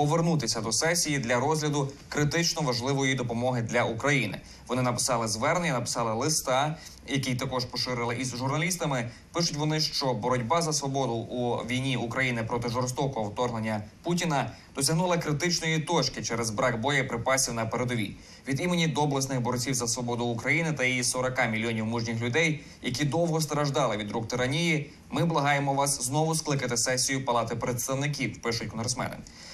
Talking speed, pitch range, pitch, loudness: 140 wpm, 120-150 Hz, 130 Hz, -28 LUFS